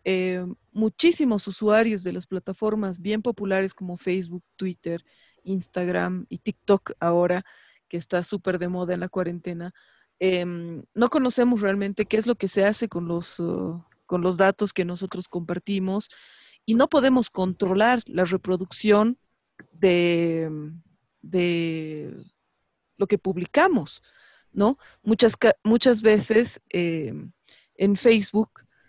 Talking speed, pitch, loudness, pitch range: 125 wpm, 190 Hz, -24 LUFS, 175-215 Hz